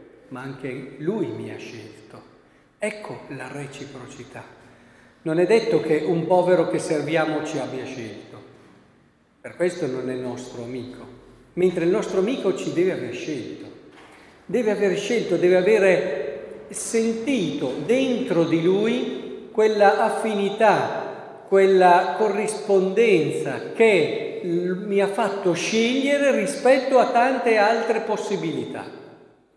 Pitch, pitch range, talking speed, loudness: 190 Hz, 155-225 Hz, 115 wpm, -21 LUFS